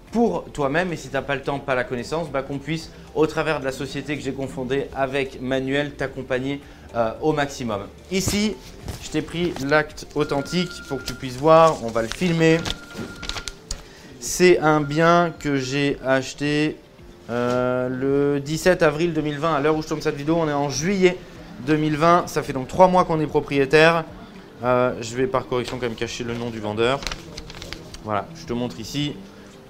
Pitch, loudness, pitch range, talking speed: 140 Hz, -22 LUFS, 130-160 Hz, 185 wpm